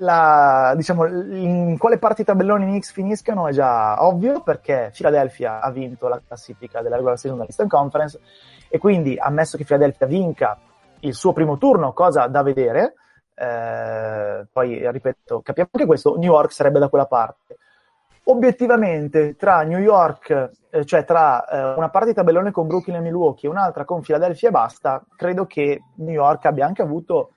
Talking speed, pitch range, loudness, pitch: 165 wpm, 135-195 Hz, -18 LUFS, 165 Hz